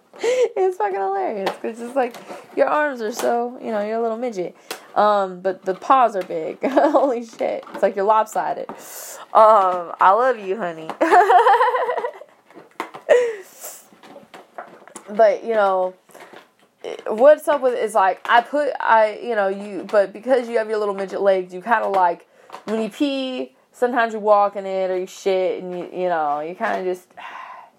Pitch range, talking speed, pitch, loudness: 190-290 Hz, 175 wpm, 220 Hz, -19 LUFS